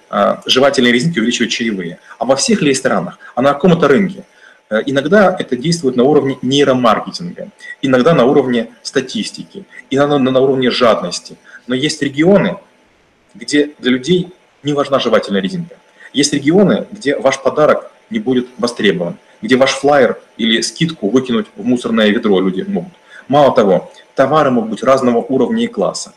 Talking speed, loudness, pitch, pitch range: 145 wpm, -13 LUFS, 135 Hz, 125-160 Hz